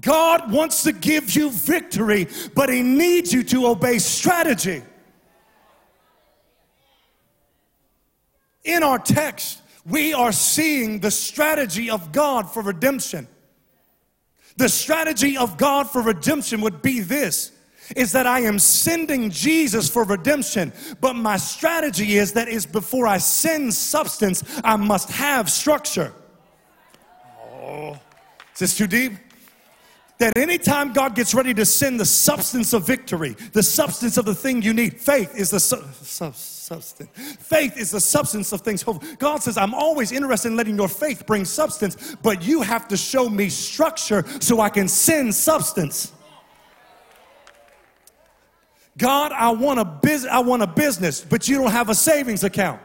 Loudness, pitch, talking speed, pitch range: -19 LUFS, 240 Hz, 150 wpm, 210-285 Hz